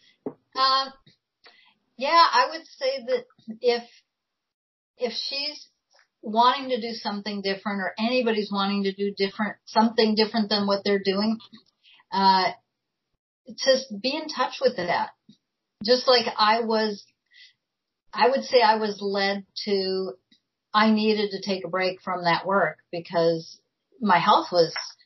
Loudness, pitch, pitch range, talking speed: -24 LUFS, 220 Hz, 200-255 Hz, 135 wpm